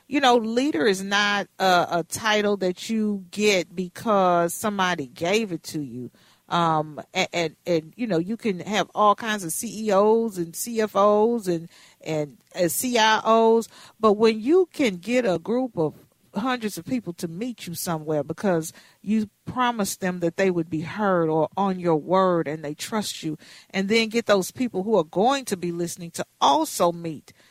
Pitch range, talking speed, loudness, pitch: 170-220 Hz, 180 wpm, -23 LUFS, 190 Hz